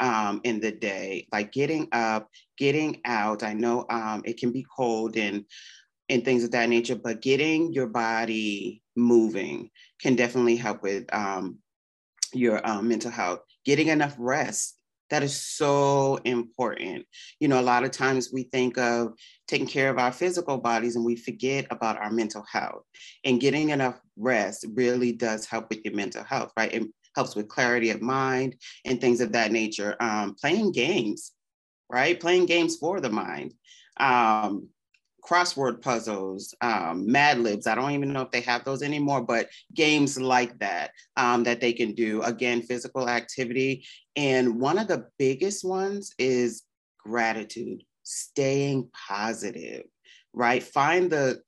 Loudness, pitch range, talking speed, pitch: -26 LUFS, 115-135 Hz, 160 wpm, 120 Hz